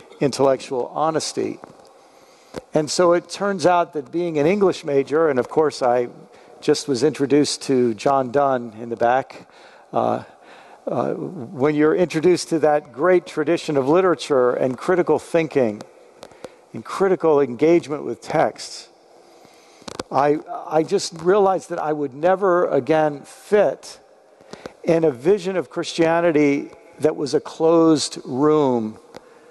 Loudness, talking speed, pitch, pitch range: -20 LUFS, 130 wpm, 155 Hz, 140-175 Hz